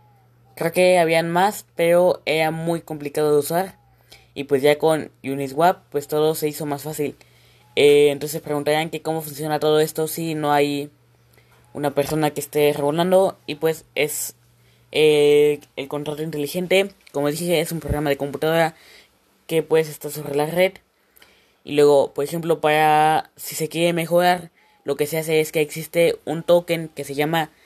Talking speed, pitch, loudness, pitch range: 170 wpm, 155 Hz, -20 LUFS, 145-165 Hz